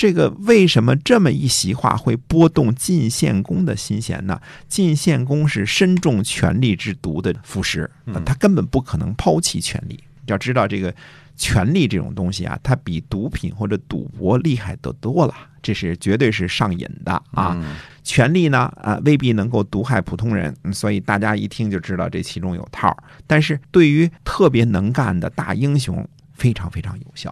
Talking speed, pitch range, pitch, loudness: 270 characters per minute, 100-150 Hz, 120 Hz, -19 LUFS